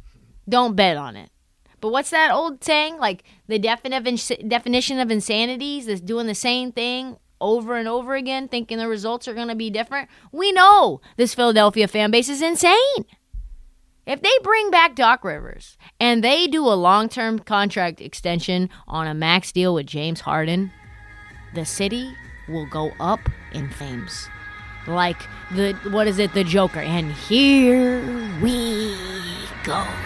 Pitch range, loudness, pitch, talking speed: 185-250 Hz, -20 LUFS, 225 Hz, 155 wpm